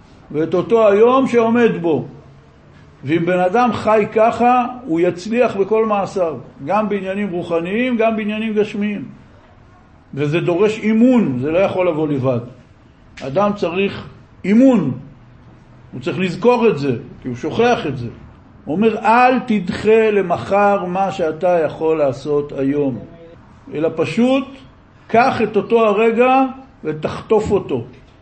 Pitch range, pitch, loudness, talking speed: 155-225 Hz, 195 Hz, -16 LUFS, 125 wpm